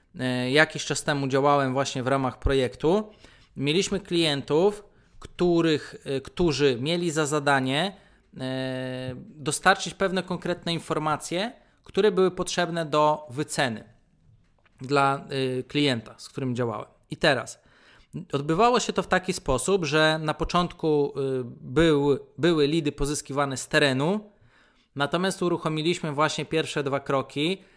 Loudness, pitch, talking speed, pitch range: -25 LUFS, 150 Hz, 110 wpm, 140-175 Hz